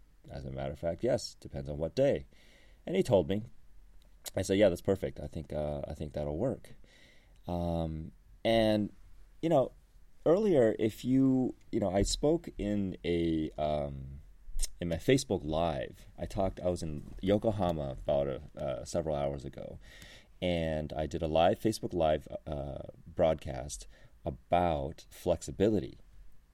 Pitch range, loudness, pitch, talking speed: 75-100 Hz, -32 LUFS, 85 Hz, 150 wpm